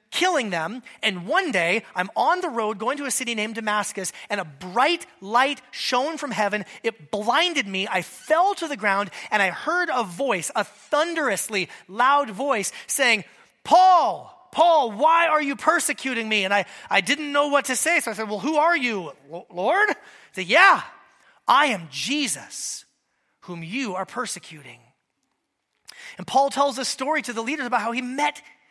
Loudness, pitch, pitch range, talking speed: -22 LUFS, 245 Hz, 205-295 Hz, 180 wpm